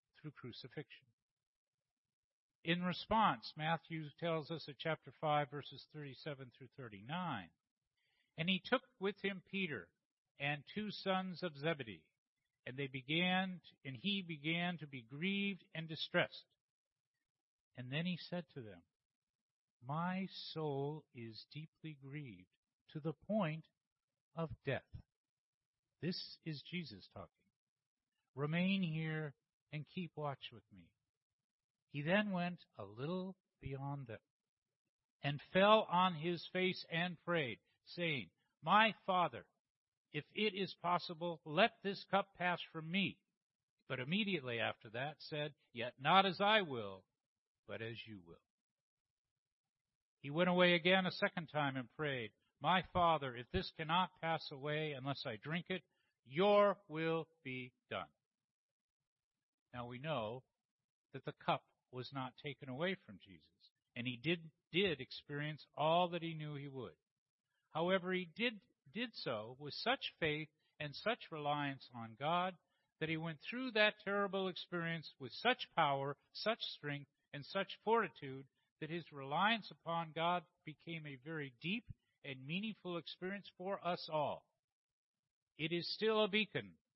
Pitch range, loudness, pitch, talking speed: 140-180 Hz, -40 LUFS, 160 Hz, 135 wpm